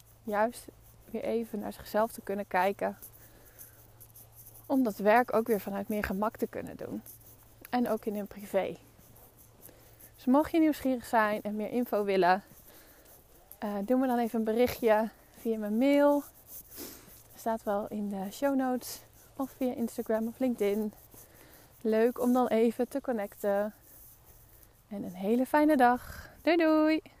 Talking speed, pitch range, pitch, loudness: 150 wpm, 195-245 Hz, 220 Hz, -30 LUFS